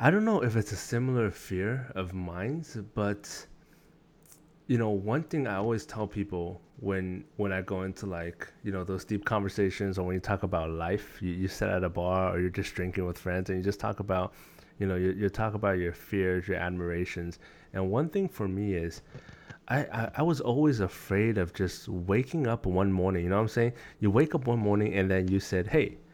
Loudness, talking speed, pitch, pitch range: -30 LUFS, 220 wpm, 100 Hz, 95-115 Hz